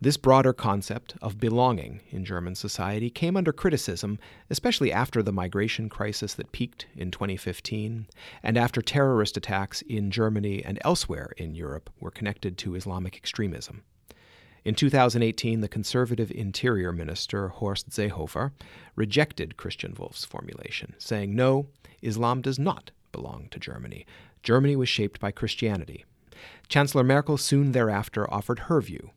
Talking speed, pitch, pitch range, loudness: 140 wpm, 110 Hz, 100-125 Hz, -27 LUFS